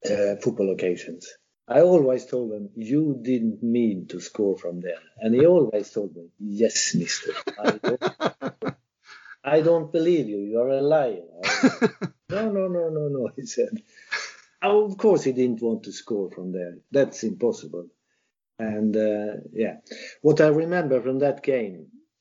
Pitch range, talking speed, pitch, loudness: 105-170 Hz, 160 wpm, 130 Hz, -24 LUFS